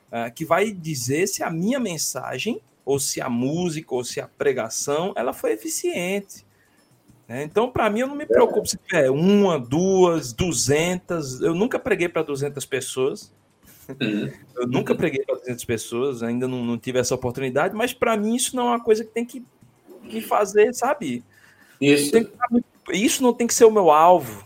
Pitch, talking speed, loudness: 170 Hz, 175 wpm, -22 LUFS